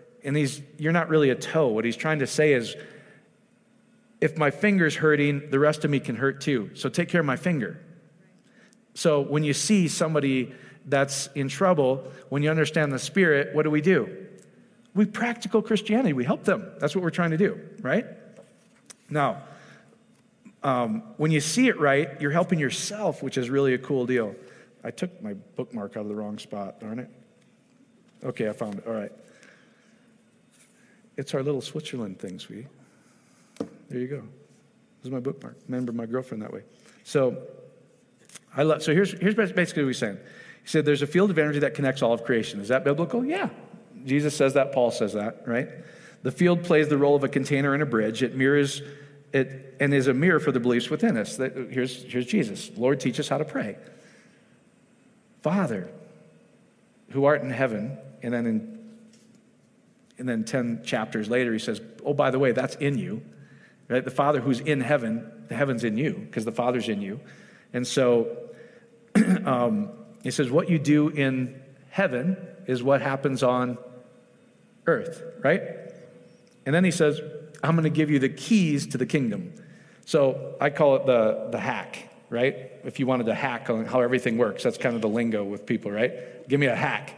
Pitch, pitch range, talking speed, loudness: 145 Hz, 130-190 Hz, 190 wpm, -25 LUFS